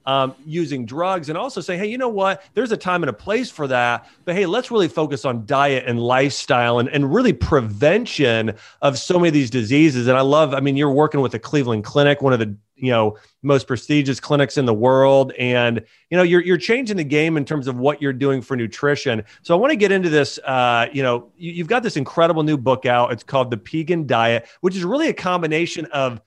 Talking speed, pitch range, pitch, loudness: 240 wpm, 125-170 Hz, 140 Hz, -19 LUFS